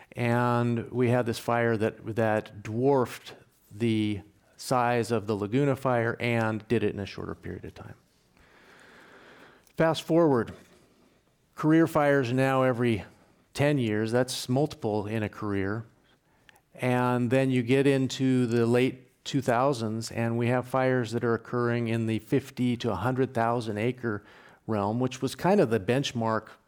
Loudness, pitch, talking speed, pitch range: -27 LUFS, 120 Hz, 145 wpm, 110-130 Hz